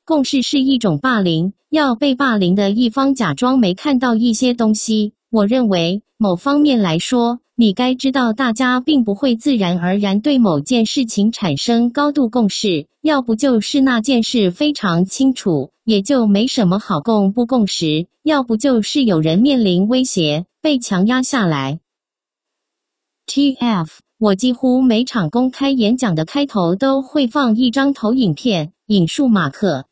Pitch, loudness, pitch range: 235 Hz, -16 LUFS, 195-270 Hz